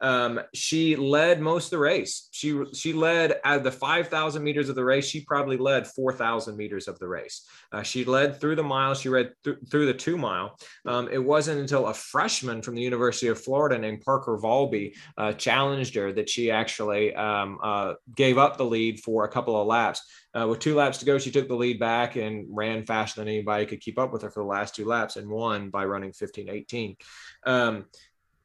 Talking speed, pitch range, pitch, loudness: 210 wpm, 110-140 Hz, 125 Hz, -26 LUFS